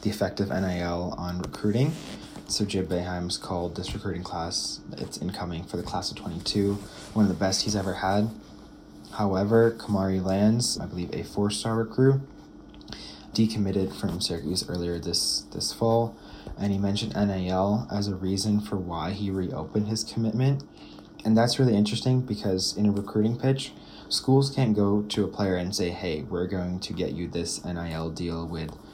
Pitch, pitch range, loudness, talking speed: 100 Hz, 90-110 Hz, -27 LUFS, 170 wpm